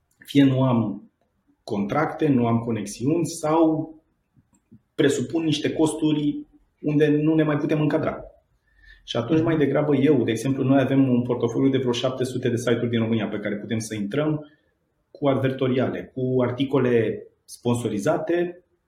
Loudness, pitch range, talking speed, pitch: -23 LUFS, 120-155 Hz, 145 wpm, 135 Hz